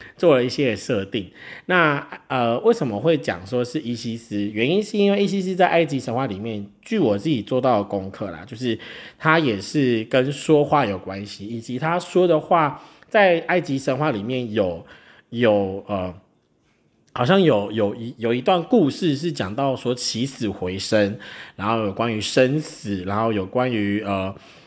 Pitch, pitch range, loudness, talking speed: 120 Hz, 105-150 Hz, -21 LUFS, 250 characters per minute